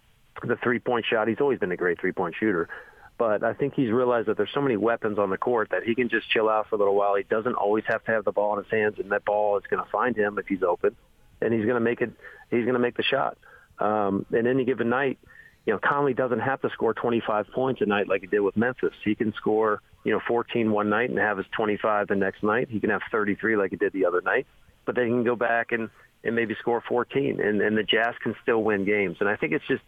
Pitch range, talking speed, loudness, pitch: 105-120 Hz, 275 wpm, -25 LUFS, 110 Hz